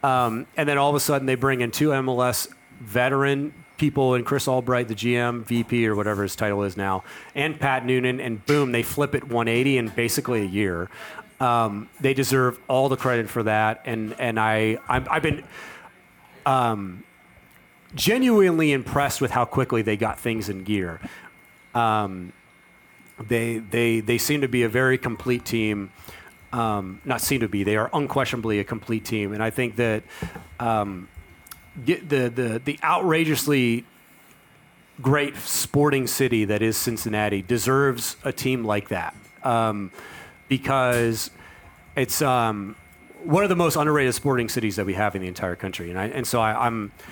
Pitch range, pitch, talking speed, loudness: 110-135 Hz, 120 Hz, 165 wpm, -23 LUFS